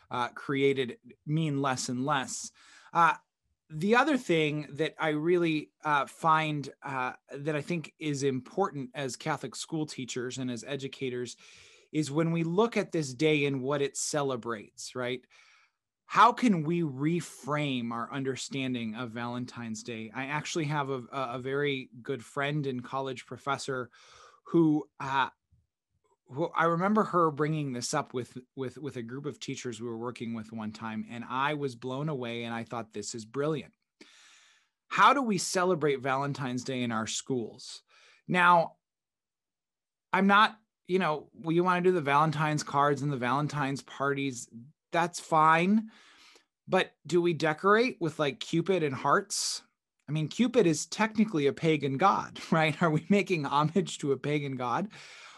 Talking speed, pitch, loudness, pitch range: 160 wpm, 145 Hz, -30 LUFS, 130-165 Hz